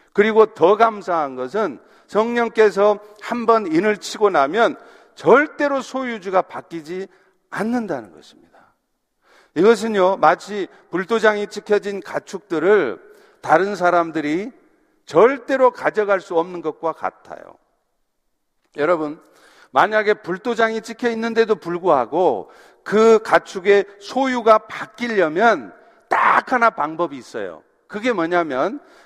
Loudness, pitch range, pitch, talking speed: -18 LUFS, 175-230 Hz, 210 Hz, 250 characters per minute